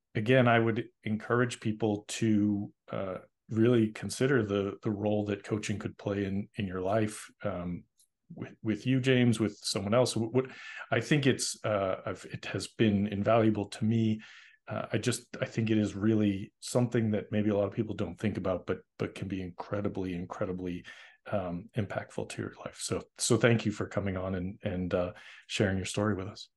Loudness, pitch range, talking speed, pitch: -31 LUFS, 100-115 Hz, 190 wpm, 110 Hz